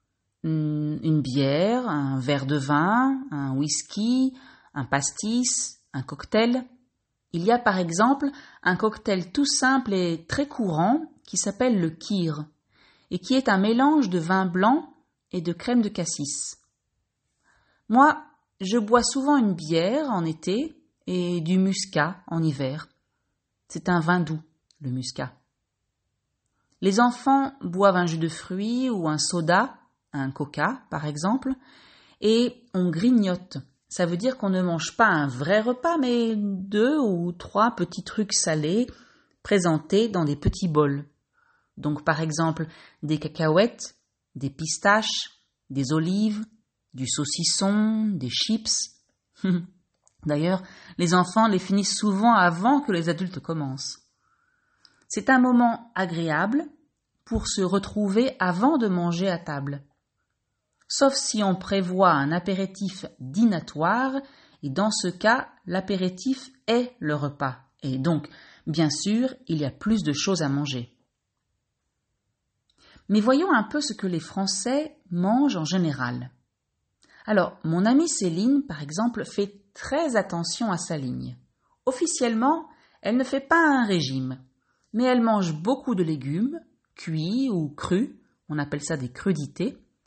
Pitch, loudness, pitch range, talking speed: 185 Hz, -24 LUFS, 155-235 Hz, 135 wpm